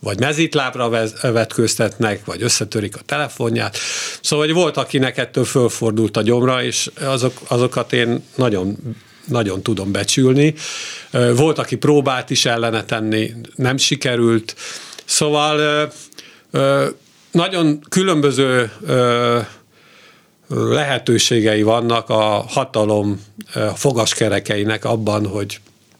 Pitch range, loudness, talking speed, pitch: 110-135 Hz, -17 LUFS, 95 wpm, 120 Hz